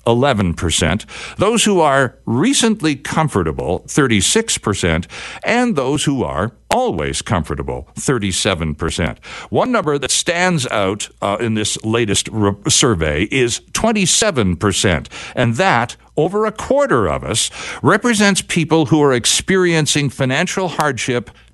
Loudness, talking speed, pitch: -16 LUFS, 115 wpm, 140 Hz